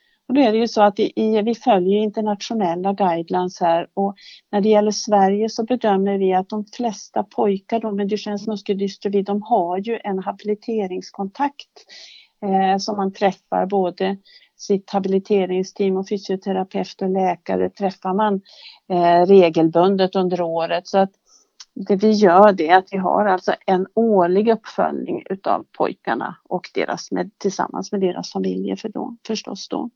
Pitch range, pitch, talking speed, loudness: 190-215 Hz, 200 Hz, 155 wpm, -20 LUFS